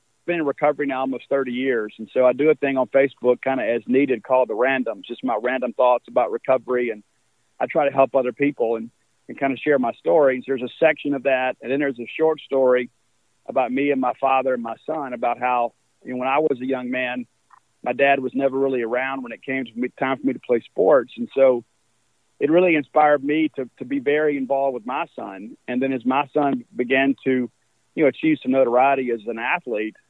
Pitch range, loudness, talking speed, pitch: 120-140 Hz, -21 LUFS, 235 wpm, 130 Hz